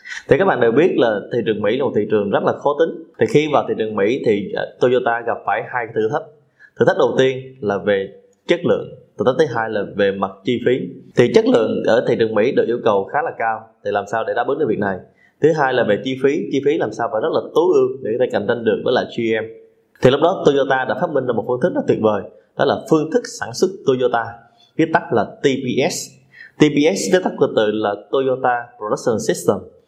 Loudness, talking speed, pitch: -18 LUFS, 255 wpm, 165 Hz